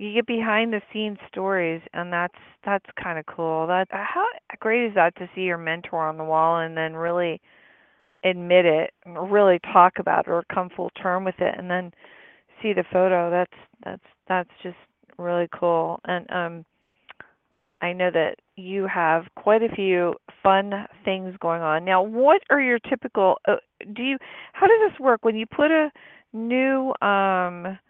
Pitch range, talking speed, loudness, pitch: 175-220 Hz, 175 wpm, -23 LUFS, 185 Hz